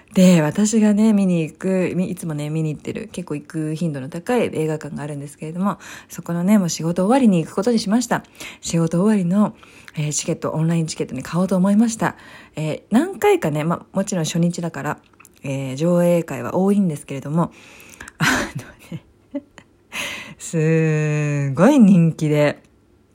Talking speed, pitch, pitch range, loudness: 345 characters per minute, 170 Hz, 155-195 Hz, -19 LUFS